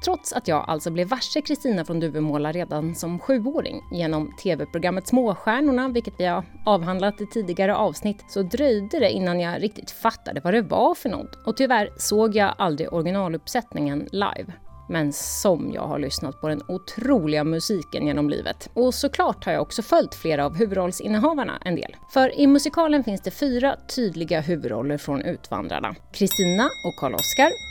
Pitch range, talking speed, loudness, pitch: 165-250 Hz, 165 wpm, -23 LUFS, 200 Hz